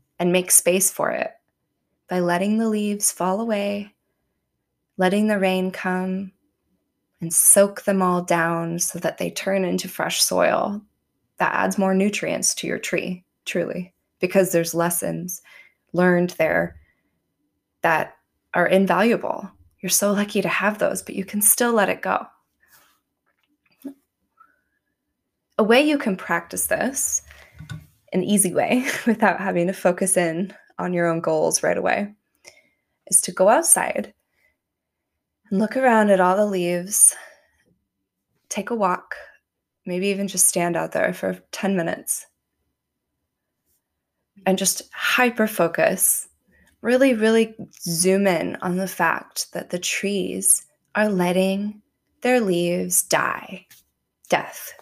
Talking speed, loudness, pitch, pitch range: 130 wpm, -20 LUFS, 190 Hz, 180-210 Hz